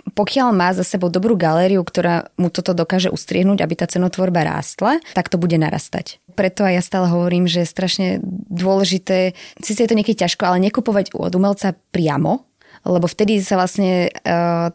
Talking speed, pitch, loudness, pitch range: 175 wpm, 185 Hz, -17 LUFS, 175-195 Hz